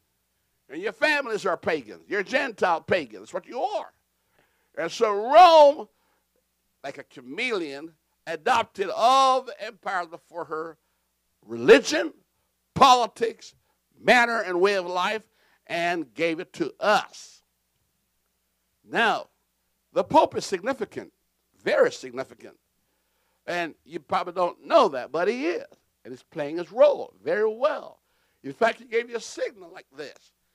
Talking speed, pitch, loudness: 135 wpm, 235 Hz, -23 LUFS